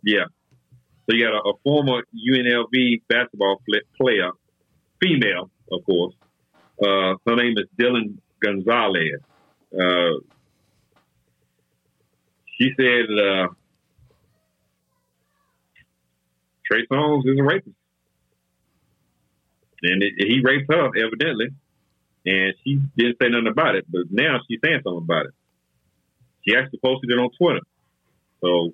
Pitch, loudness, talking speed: 105 Hz, -20 LUFS, 120 wpm